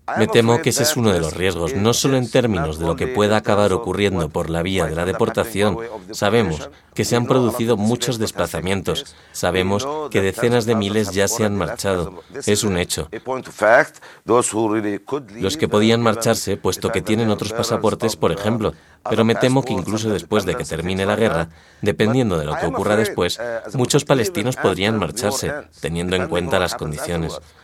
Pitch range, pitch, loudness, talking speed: 95-115 Hz, 105 Hz, -19 LUFS, 175 wpm